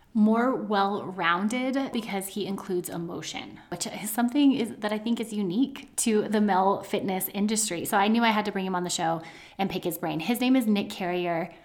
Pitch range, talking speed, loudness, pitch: 185-230 Hz, 205 wpm, -27 LUFS, 205 Hz